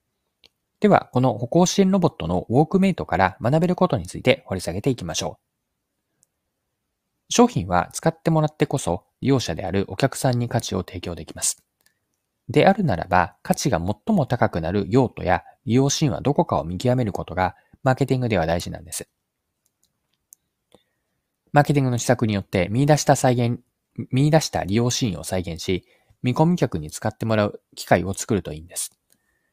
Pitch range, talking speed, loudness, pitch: 95-145 Hz, 365 characters per minute, -22 LUFS, 120 Hz